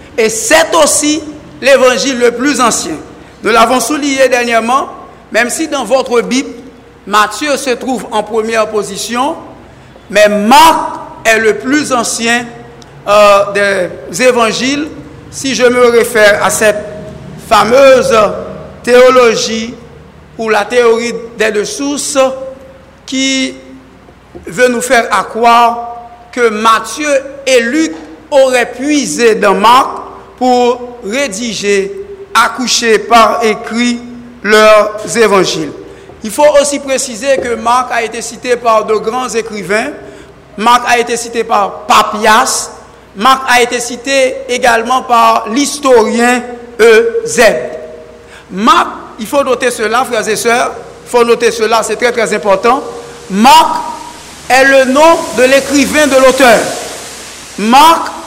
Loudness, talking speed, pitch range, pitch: -9 LUFS, 120 wpm, 225-265 Hz, 240 Hz